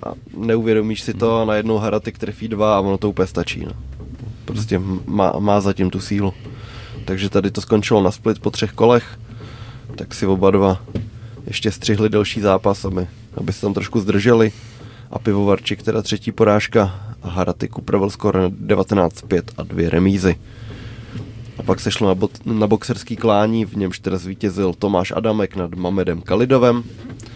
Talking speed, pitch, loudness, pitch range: 165 wpm, 105 Hz, -19 LUFS, 95-115 Hz